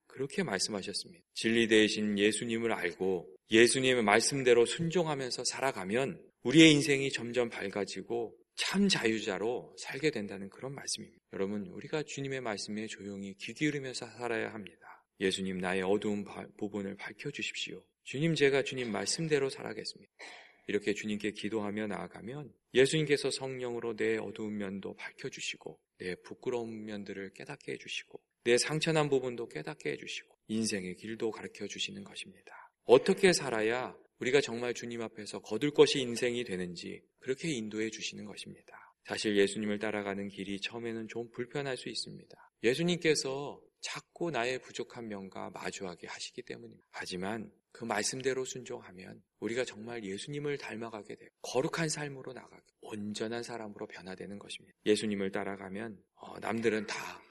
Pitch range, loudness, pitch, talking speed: 105-130 Hz, -33 LUFS, 115 Hz, 375 characters per minute